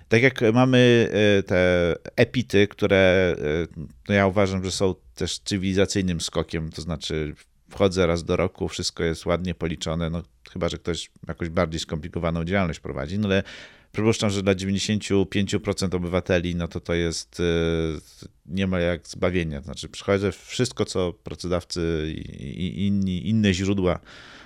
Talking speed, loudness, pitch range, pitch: 140 wpm, -24 LUFS, 85-100 Hz, 90 Hz